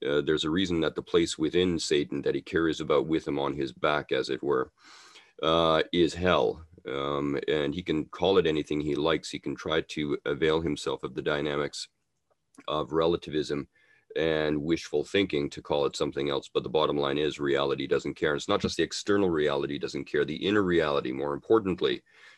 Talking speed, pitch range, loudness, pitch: 200 wpm, 70-85 Hz, -28 LUFS, 75 Hz